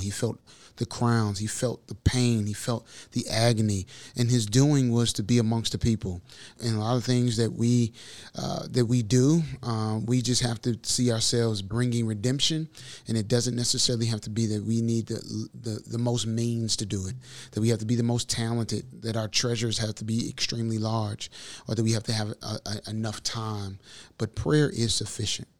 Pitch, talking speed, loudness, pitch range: 115 Hz, 210 wpm, -27 LUFS, 110-120 Hz